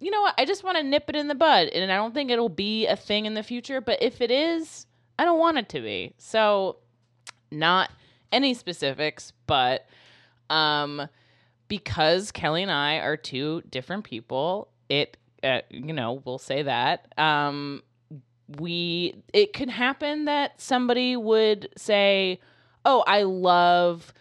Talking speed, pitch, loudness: 165 wpm, 185 Hz, -24 LUFS